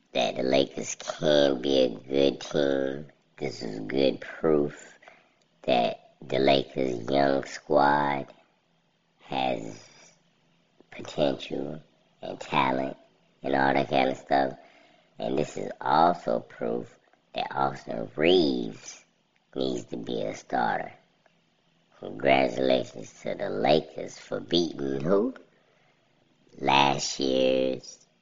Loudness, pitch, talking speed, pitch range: -27 LUFS, 70 Hz, 105 wpm, 65-70 Hz